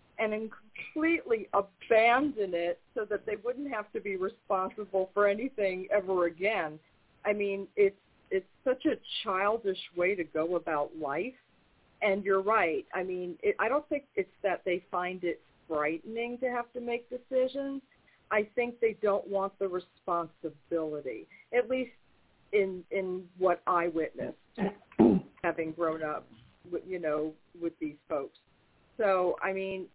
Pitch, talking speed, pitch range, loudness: 195 Hz, 150 wpm, 175-240 Hz, -32 LUFS